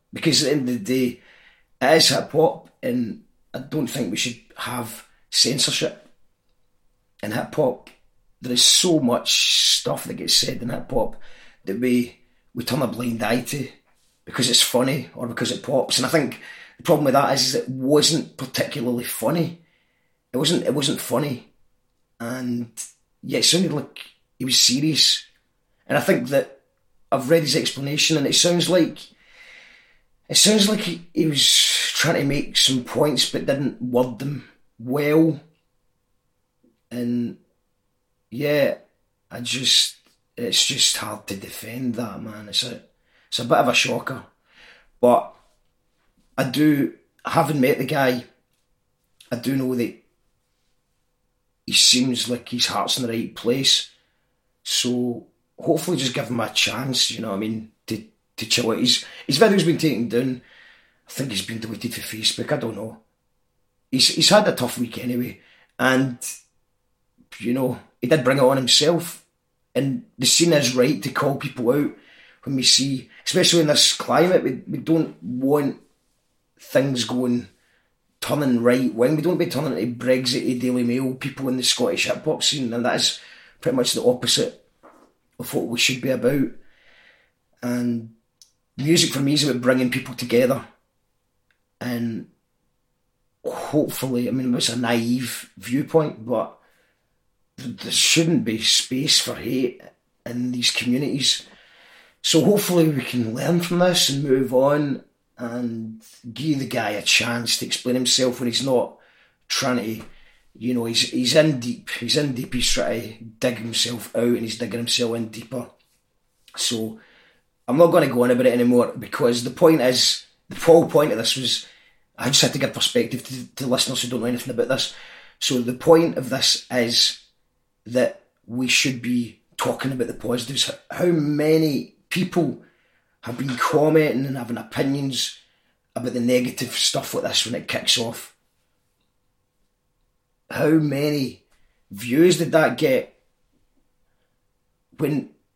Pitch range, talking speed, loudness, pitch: 120-145 Hz, 160 wpm, -20 LUFS, 125 Hz